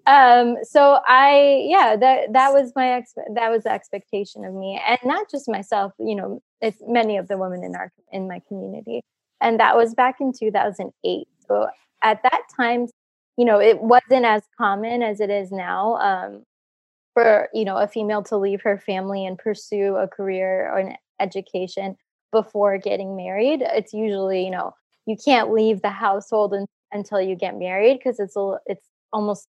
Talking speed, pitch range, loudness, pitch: 185 wpm, 195-240 Hz, -20 LUFS, 210 Hz